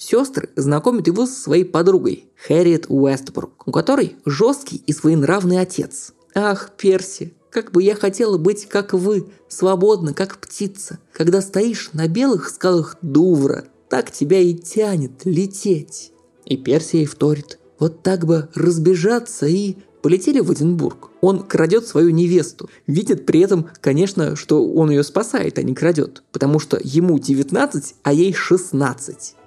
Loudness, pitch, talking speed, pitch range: -18 LUFS, 180 Hz, 145 wpm, 160-200 Hz